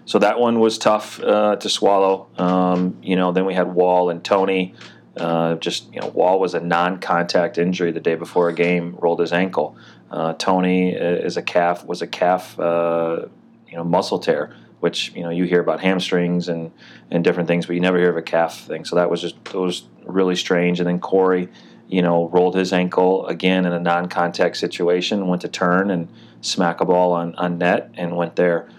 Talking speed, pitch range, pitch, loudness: 210 wpm, 85-90 Hz, 90 Hz, -19 LUFS